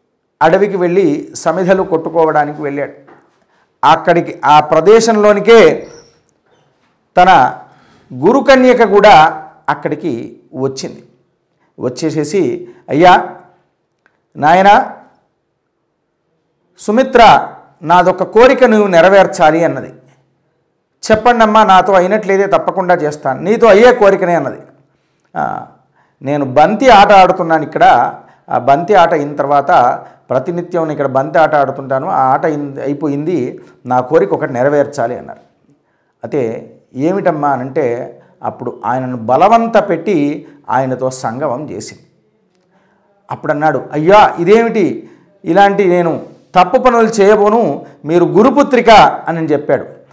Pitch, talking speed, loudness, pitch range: 175 Hz, 90 wpm, -10 LUFS, 150-210 Hz